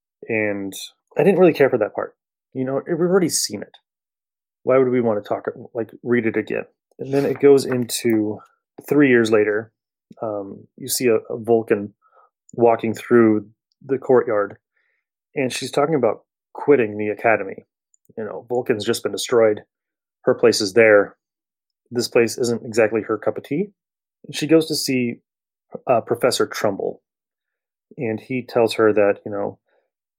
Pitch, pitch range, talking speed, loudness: 115 Hz, 105-125 Hz, 165 wpm, -20 LUFS